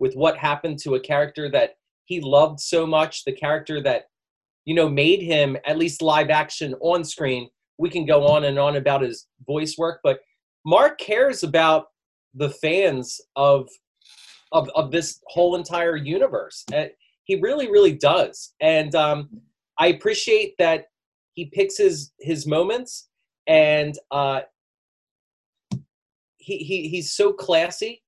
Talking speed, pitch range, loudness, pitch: 145 wpm, 145-190 Hz, -21 LUFS, 160 Hz